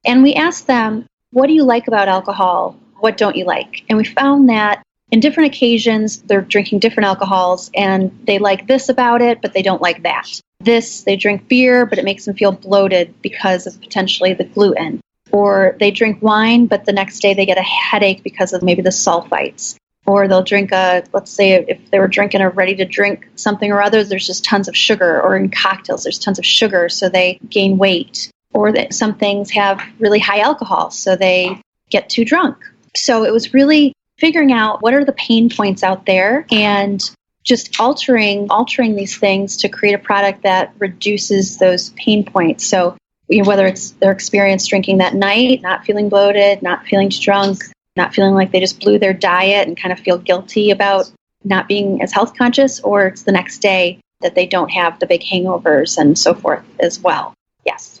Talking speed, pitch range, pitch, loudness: 200 wpm, 190-225 Hz, 200 Hz, -14 LUFS